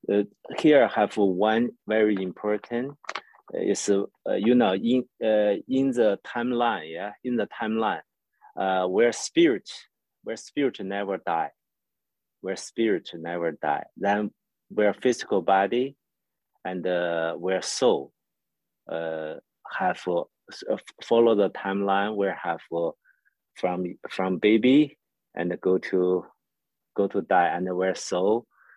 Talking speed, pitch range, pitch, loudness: 125 wpm, 90-115 Hz, 100 Hz, -25 LUFS